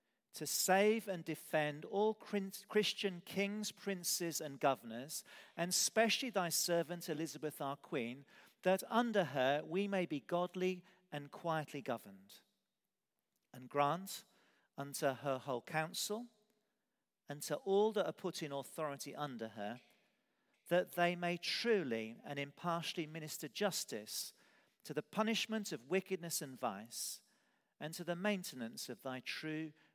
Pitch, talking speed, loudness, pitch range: 170 Hz, 130 wpm, -39 LUFS, 145-200 Hz